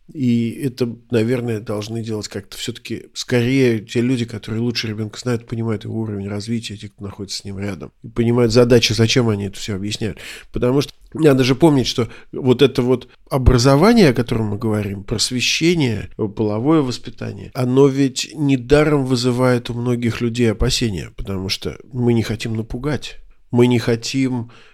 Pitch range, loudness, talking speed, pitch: 110-125 Hz, -18 LUFS, 160 wpm, 120 Hz